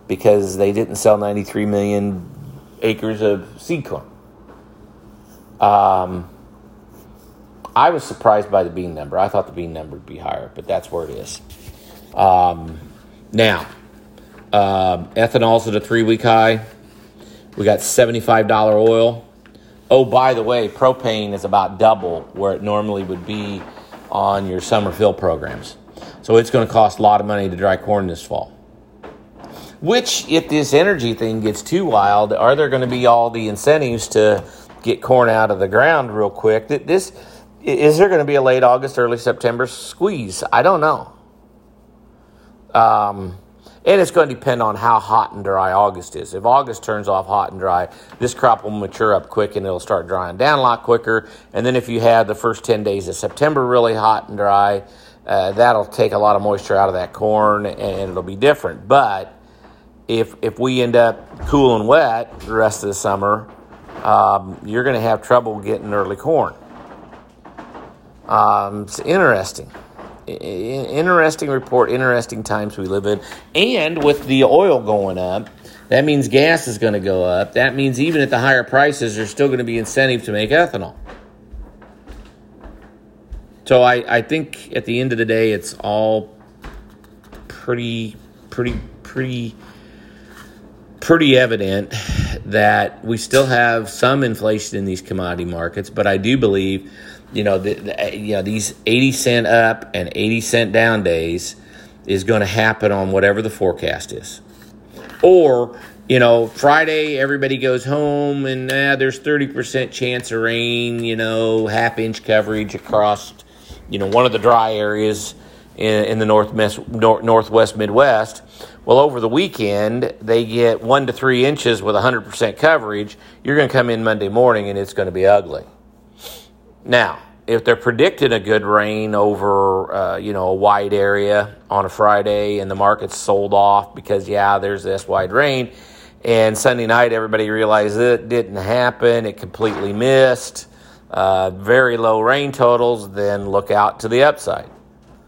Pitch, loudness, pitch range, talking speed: 110 Hz, -16 LUFS, 100-125 Hz, 170 wpm